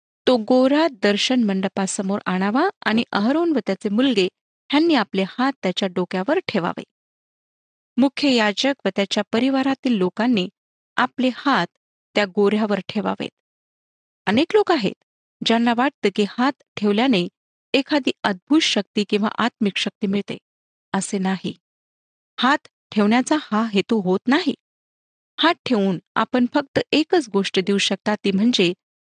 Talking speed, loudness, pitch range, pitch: 125 wpm, -20 LUFS, 200-265 Hz, 220 Hz